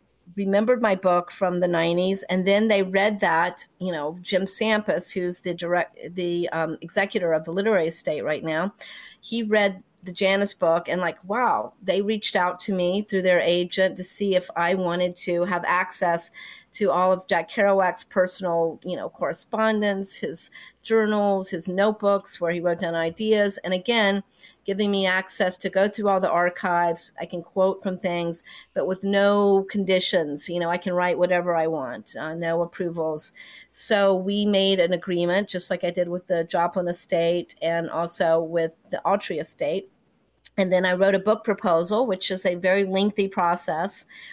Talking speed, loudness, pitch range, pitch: 180 wpm, -24 LUFS, 175-200 Hz, 185 Hz